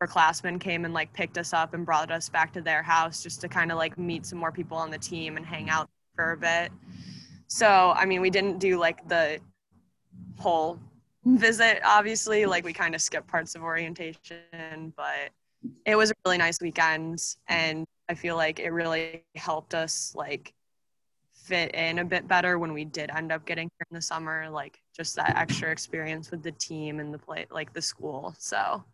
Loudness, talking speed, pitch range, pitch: -27 LUFS, 200 wpm, 160-175 Hz, 165 Hz